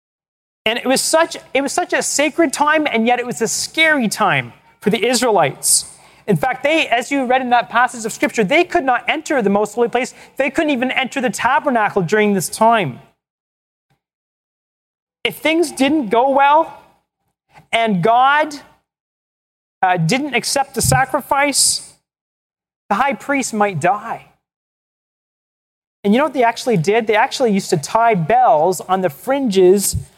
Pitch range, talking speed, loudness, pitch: 220-285 Hz, 160 wpm, -16 LUFS, 245 Hz